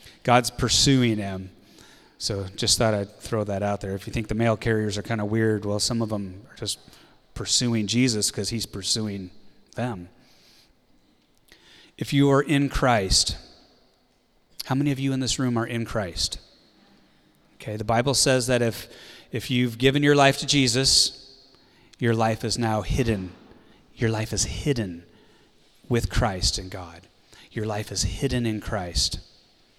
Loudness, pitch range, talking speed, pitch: -24 LUFS, 100-125 Hz, 160 wpm, 110 Hz